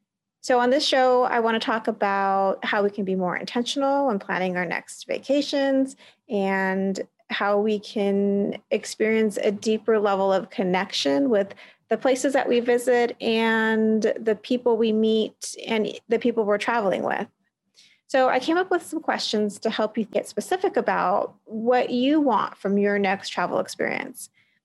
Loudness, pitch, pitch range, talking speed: -23 LUFS, 225 Hz, 205-250 Hz, 165 wpm